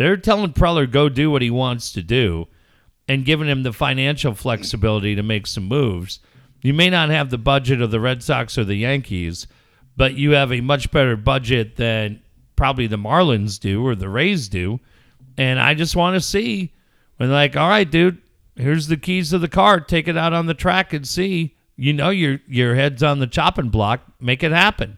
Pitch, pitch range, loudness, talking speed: 135 Hz, 115-165 Hz, -18 LUFS, 205 wpm